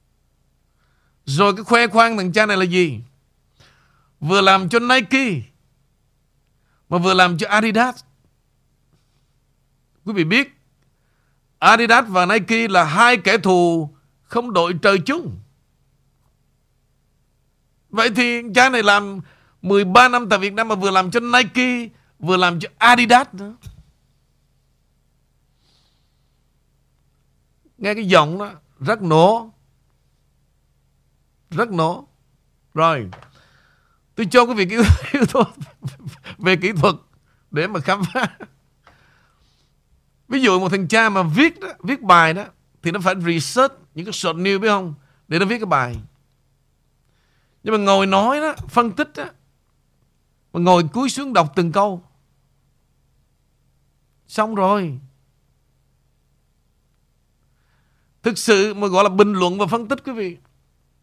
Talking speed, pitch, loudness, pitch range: 125 wpm, 190 Hz, -17 LUFS, 155-225 Hz